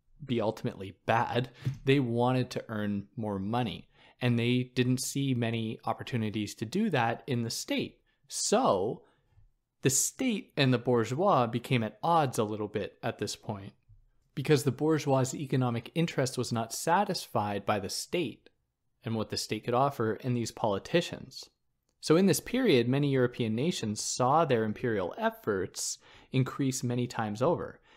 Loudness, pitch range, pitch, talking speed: -30 LUFS, 115-140 Hz, 125 Hz, 150 wpm